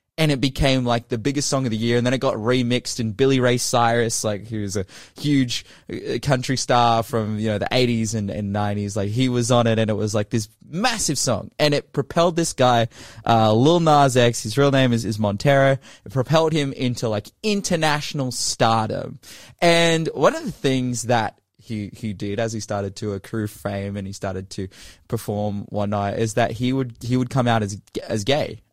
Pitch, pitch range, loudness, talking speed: 120 Hz, 105-135 Hz, -21 LUFS, 210 wpm